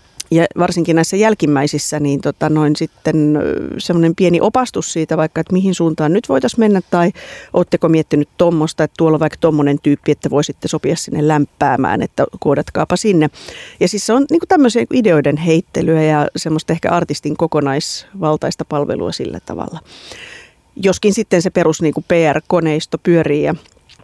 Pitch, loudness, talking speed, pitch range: 160 Hz, -15 LUFS, 150 wpm, 150-180 Hz